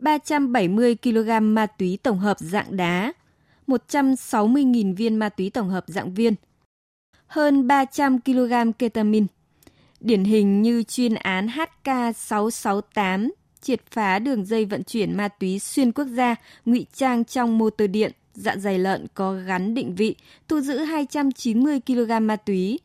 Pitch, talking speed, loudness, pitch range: 230 Hz, 145 wpm, -22 LUFS, 205-255 Hz